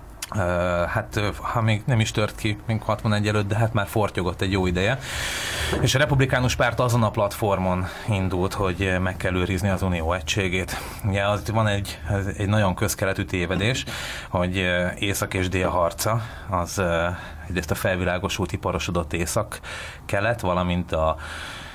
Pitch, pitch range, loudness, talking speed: 95 Hz, 90-105 Hz, -24 LUFS, 155 wpm